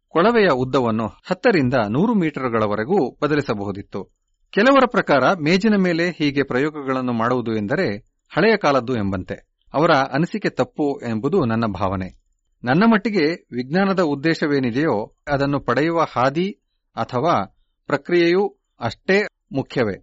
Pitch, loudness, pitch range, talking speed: 140 Hz, -20 LUFS, 115-180 Hz, 100 wpm